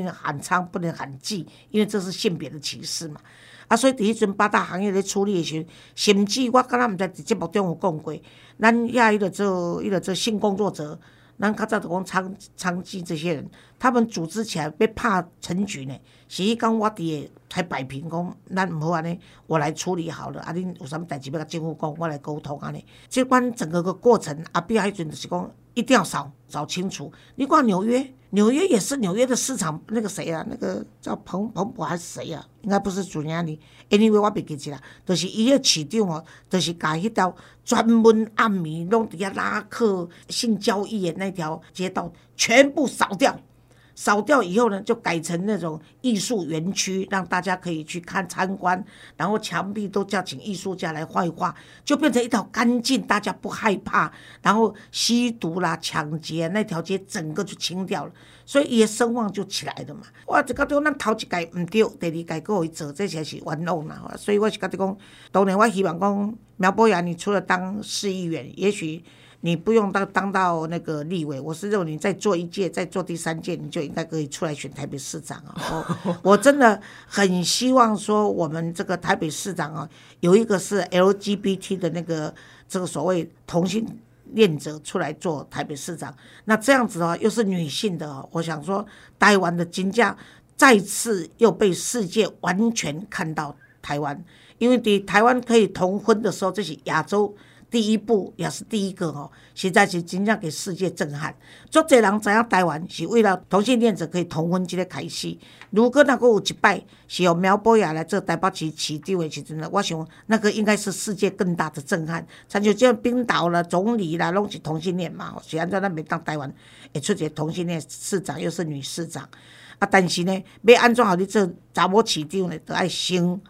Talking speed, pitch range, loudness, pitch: 290 characters per minute, 165-215 Hz, -23 LUFS, 185 Hz